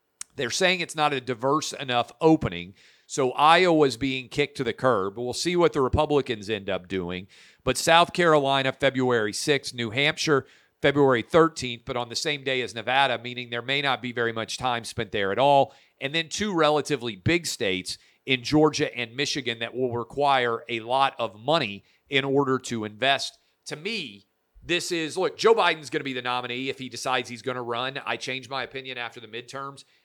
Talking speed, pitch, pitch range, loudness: 195 wpm, 130 Hz, 120-145 Hz, -25 LUFS